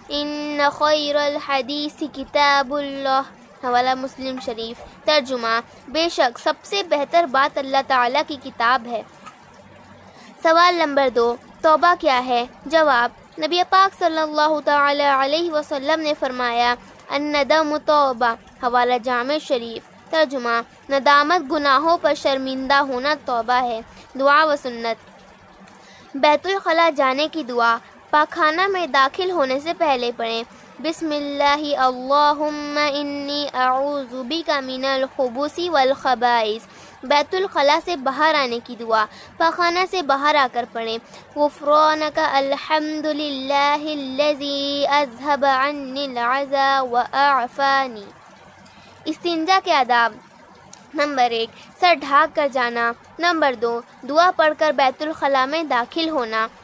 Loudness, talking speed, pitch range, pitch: -19 LUFS, 90 wpm, 255-305 Hz, 285 Hz